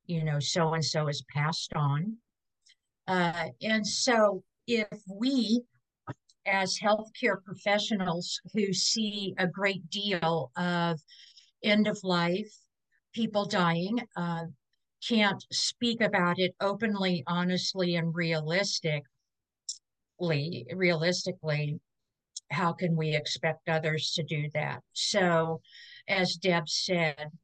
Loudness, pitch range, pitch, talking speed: -29 LUFS, 160-200 Hz, 175 Hz, 105 wpm